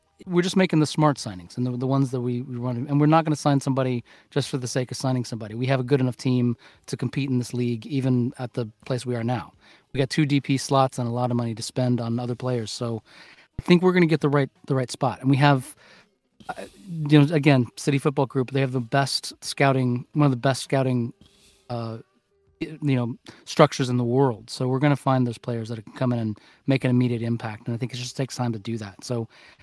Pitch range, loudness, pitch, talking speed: 120-140 Hz, -24 LUFS, 130 Hz, 255 wpm